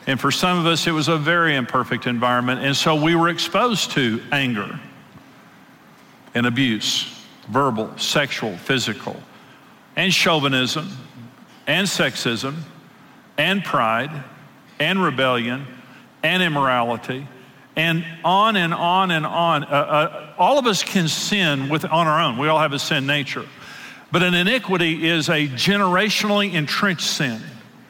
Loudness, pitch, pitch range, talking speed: -19 LUFS, 155 Hz, 130-175 Hz, 140 wpm